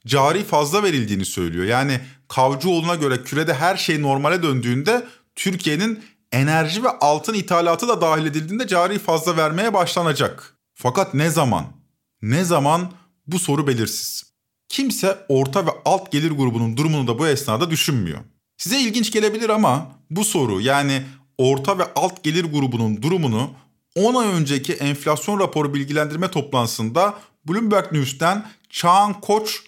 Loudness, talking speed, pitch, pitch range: -20 LUFS, 135 wpm, 155 Hz, 135-190 Hz